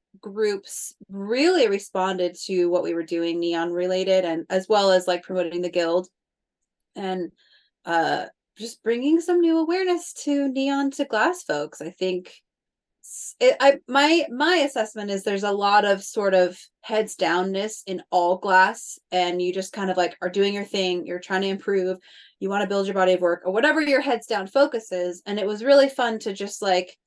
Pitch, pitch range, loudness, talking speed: 200 Hz, 180-245 Hz, -23 LUFS, 190 wpm